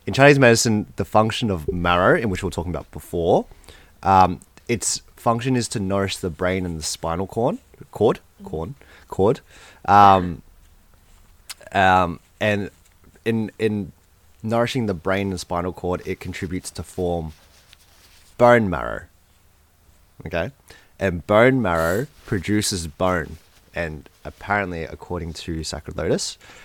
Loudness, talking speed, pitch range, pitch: -21 LUFS, 130 wpm, 80-100 Hz, 90 Hz